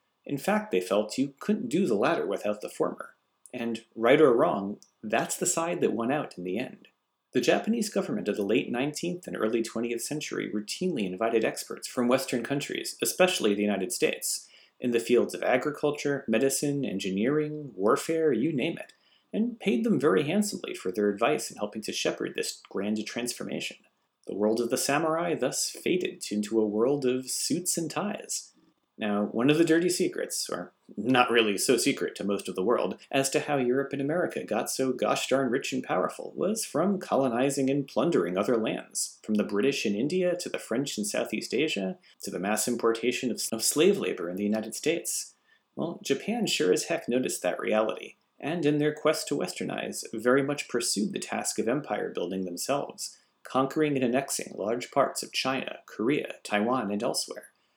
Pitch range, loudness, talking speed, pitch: 110-150 Hz, -28 LUFS, 185 wpm, 125 Hz